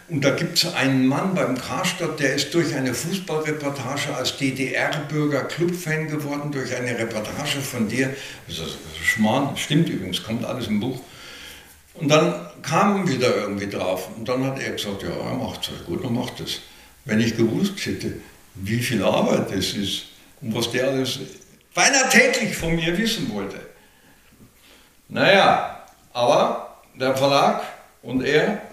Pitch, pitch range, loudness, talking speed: 135 Hz, 115-160 Hz, -22 LUFS, 160 wpm